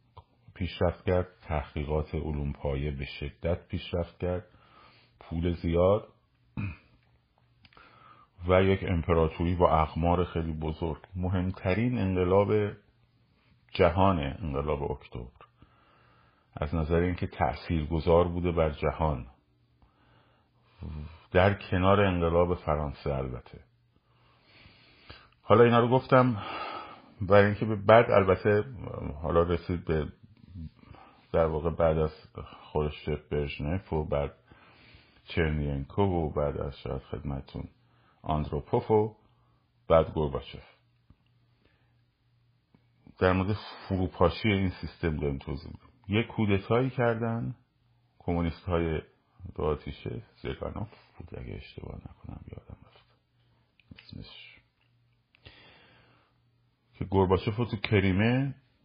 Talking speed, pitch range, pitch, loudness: 95 wpm, 80-115 Hz, 95 Hz, -28 LUFS